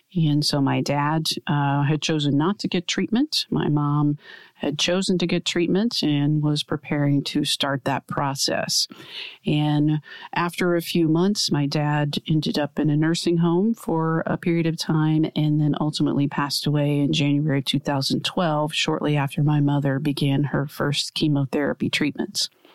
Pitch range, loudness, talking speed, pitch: 145-170 Hz, -22 LUFS, 160 wpm, 150 Hz